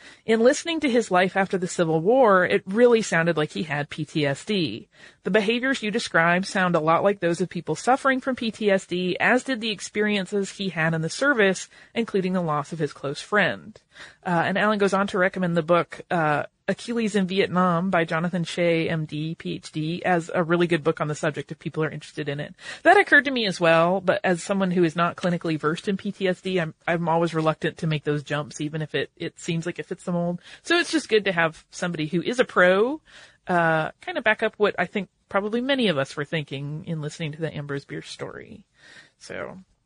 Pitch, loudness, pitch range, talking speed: 180 Hz, -23 LUFS, 160-205 Hz, 220 wpm